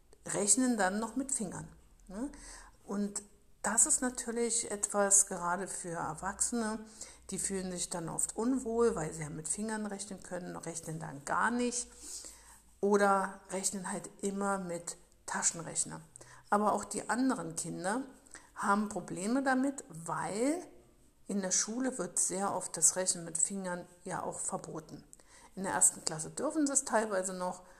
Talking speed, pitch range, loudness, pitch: 145 wpm, 180-235 Hz, -33 LUFS, 200 Hz